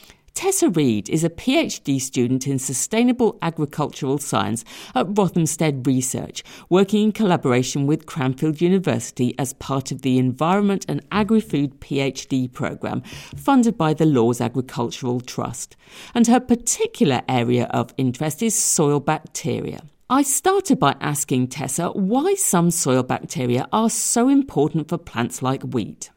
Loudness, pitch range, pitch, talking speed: -20 LUFS, 130-205 Hz, 150 Hz, 135 wpm